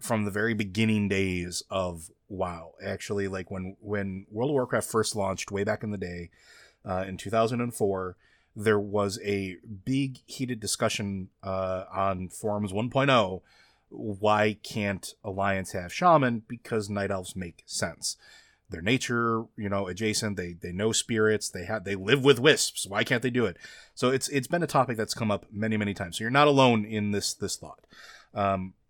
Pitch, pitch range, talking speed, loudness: 105 Hz, 95-115 Hz, 175 wpm, -28 LUFS